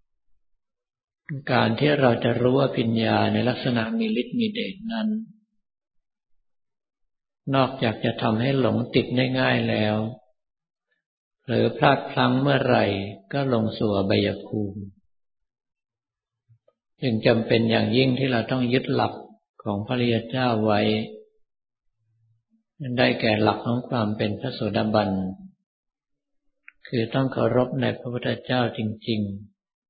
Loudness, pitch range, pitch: -23 LUFS, 110-130 Hz, 120 Hz